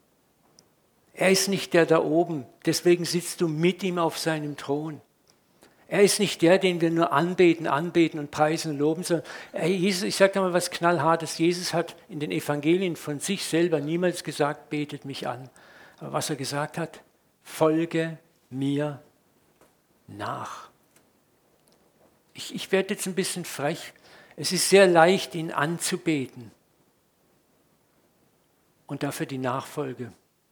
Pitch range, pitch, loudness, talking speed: 150-175 Hz, 165 Hz, -25 LUFS, 140 wpm